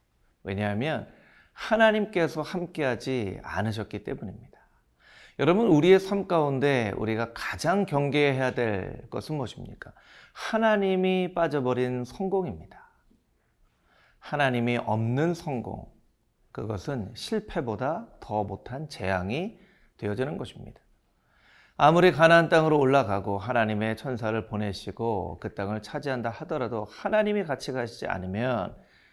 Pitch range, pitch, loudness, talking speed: 110-165 Hz, 130 Hz, -27 LUFS, 285 characters per minute